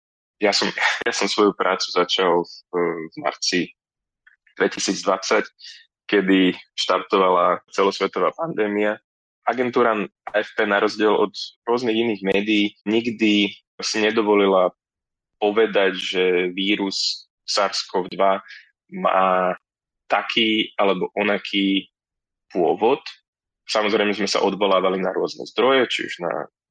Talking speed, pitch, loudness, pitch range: 100 wpm, 100 Hz, -21 LUFS, 95-105 Hz